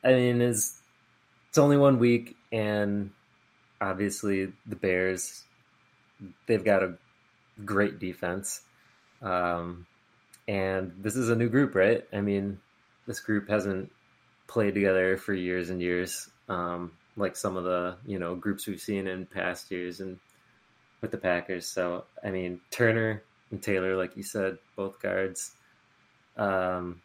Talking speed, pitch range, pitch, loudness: 140 wpm, 90-105 Hz, 95 Hz, -29 LUFS